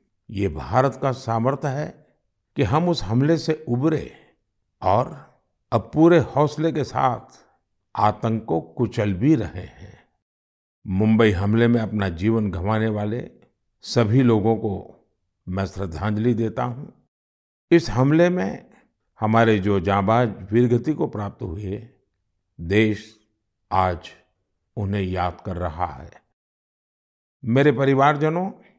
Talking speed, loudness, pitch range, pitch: 115 wpm, -22 LUFS, 95-130 Hz, 110 Hz